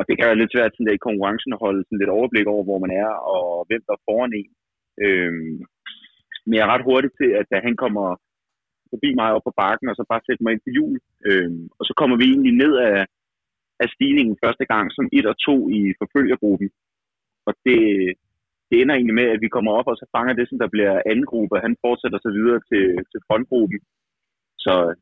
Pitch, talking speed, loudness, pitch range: 115 Hz, 225 wpm, -19 LUFS, 100-125 Hz